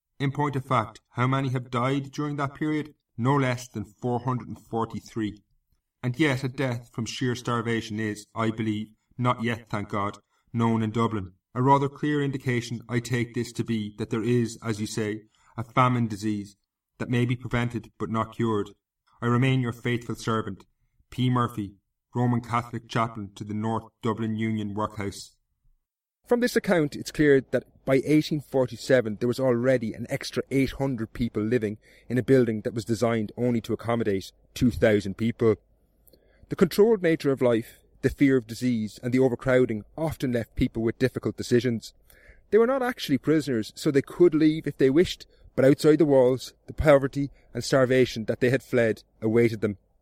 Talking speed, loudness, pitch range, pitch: 180 wpm, -26 LUFS, 110-135 Hz, 120 Hz